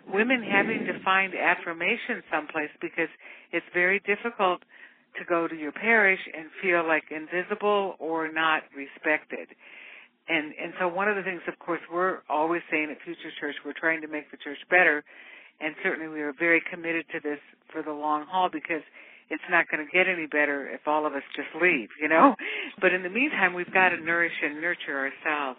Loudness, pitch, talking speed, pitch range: -26 LUFS, 165 Hz, 195 wpm, 155-180 Hz